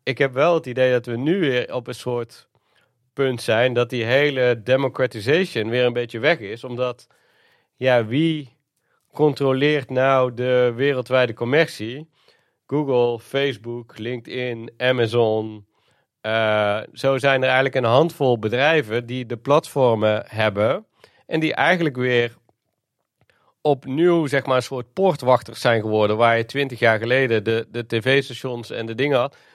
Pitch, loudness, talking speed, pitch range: 125 Hz, -20 LUFS, 145 wpm, 115-135 Hz